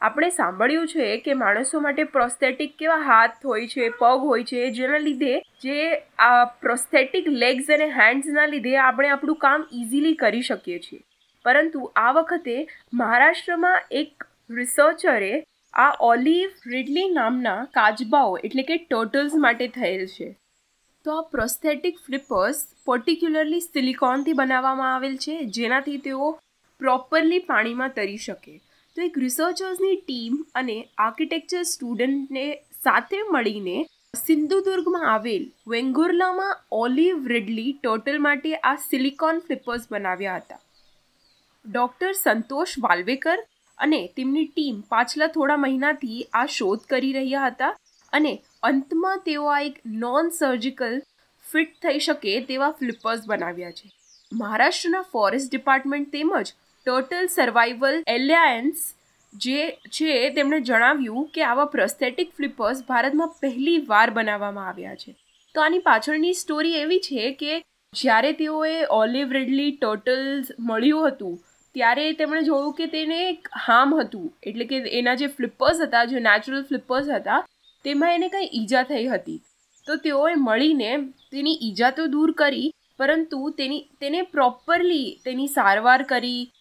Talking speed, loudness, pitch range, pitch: 130 wpm, -22 LUFS, 245-310 Hz, 275 Hz